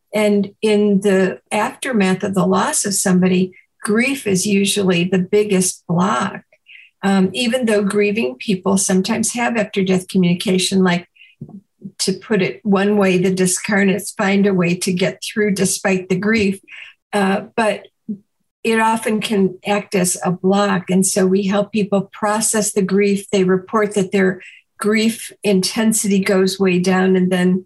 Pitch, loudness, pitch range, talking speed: 200 Hz, -17 LUFS, 190-210 Hz, 150 wpm